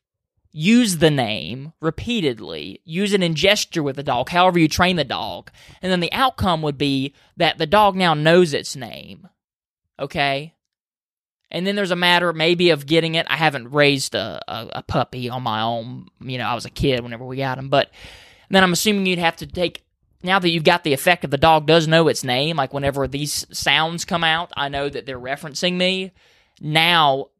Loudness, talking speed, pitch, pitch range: -19 LUFS, 205 wpm, 160 Hz, 135-175 Hz